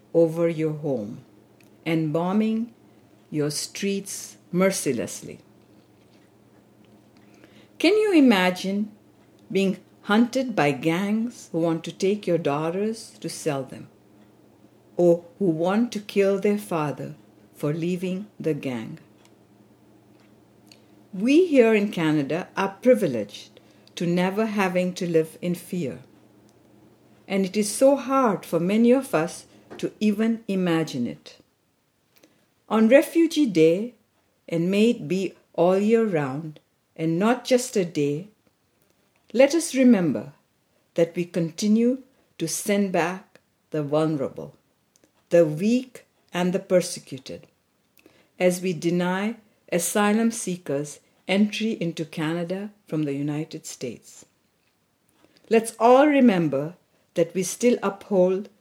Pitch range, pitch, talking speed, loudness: 160-215 Hz, 185 Hz, 115 wpm, -23 LUFS